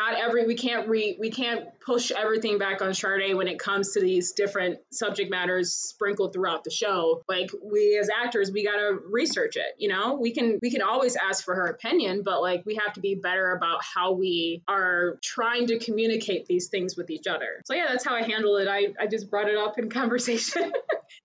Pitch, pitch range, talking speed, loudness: 205 Hz, 190-235 Hz, 215 wpm, -26 LUFS